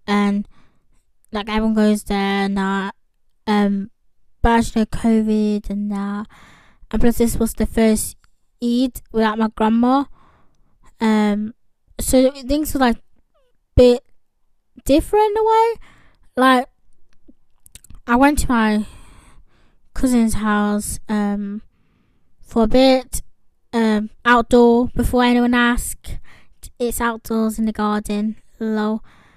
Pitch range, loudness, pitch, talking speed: 210-245 Hz, -18 LUFS, 225 Hz, 115 wpm